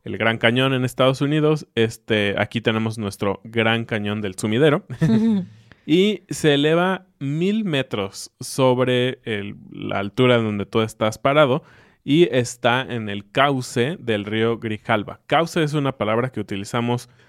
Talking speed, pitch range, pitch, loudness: 140 wpm, 110-145 Hz, 120 Hz, -21 LUFS